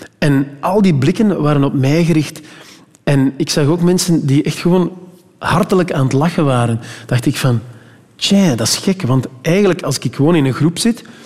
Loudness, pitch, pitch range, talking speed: -14 LUFS, 155 Hz, 135-180 Hz, 195 wpm